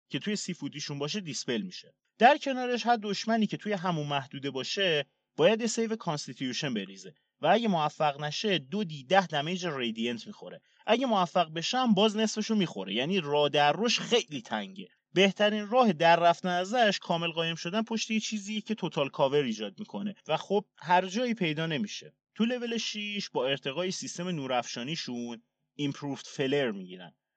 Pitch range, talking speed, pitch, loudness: 145-215 Hz, 160 wpm, 180 Hz, -29 LUFS